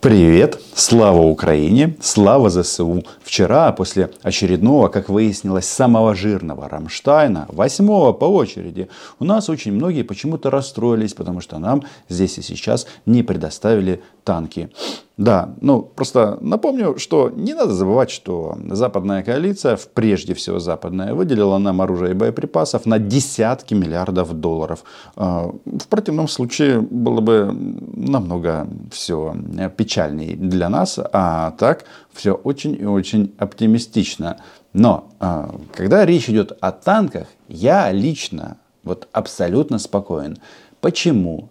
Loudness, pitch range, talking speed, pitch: -17 LUFS, 90-120 Hz, 120 wpm, 100 Hz